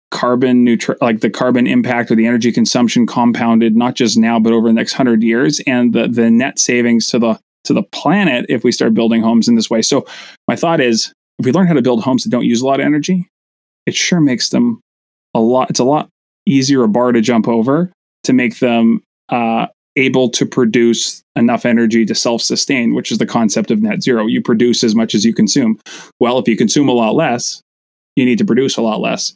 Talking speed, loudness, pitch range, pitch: 225 wpm, -13 LUFS, 115-140 Hz, 120 Hz